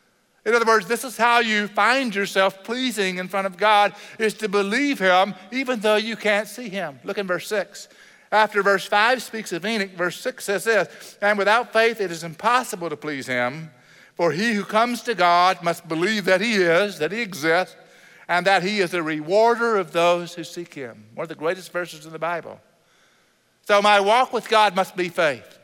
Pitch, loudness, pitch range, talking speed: 200 Hz, -21 LUFS, 175-220 Hz, 205 wpm